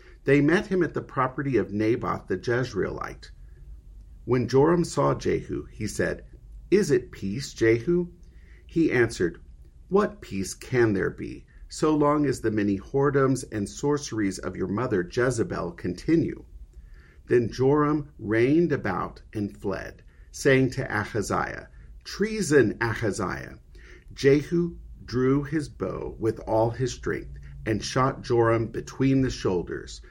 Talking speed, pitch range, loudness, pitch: 130 wpm, 95-140 Hz, -26 LUFS, 115 Hz